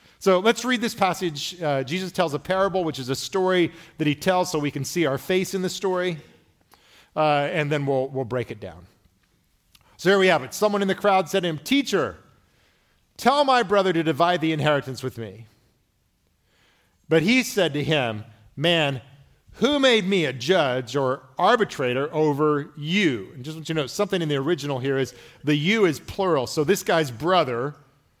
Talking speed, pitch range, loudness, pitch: 195 wpm, 135-185 Hz, -23 LUFS, 155 Hz